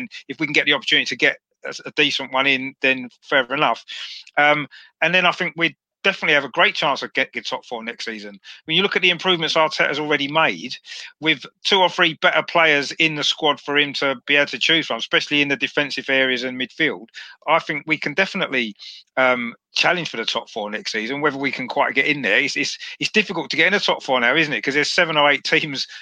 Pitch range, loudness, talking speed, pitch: 135-165 Hz, -19 LUFS, 245 wpm, 150 Hz